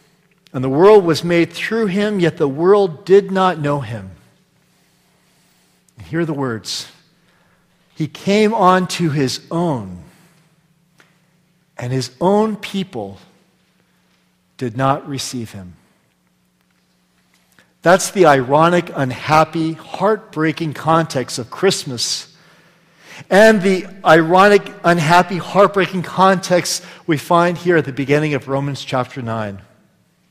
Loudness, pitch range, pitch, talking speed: -16 LUFS, 130-180 Hz, 165 Hz, 115 wpm